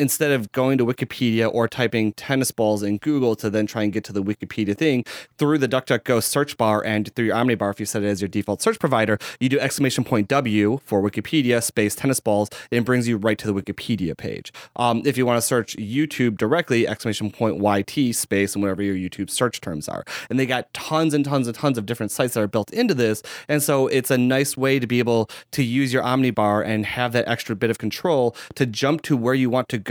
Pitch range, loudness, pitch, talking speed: 105-130 Hz, -22 LUFS, 120 Hz, 240 wpm